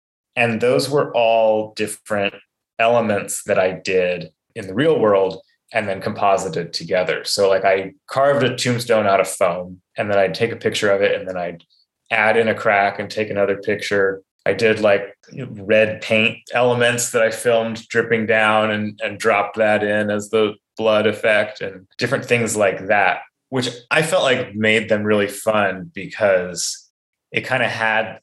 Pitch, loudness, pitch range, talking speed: 110 Hz, -18 LUFS, 105-120 Hz, 175 wpm